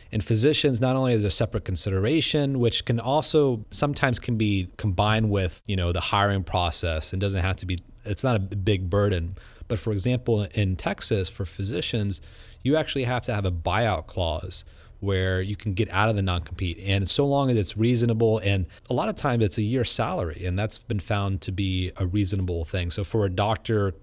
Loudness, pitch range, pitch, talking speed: -25 LUFS, 95-115 Hz, 105 Hz, 205 wpm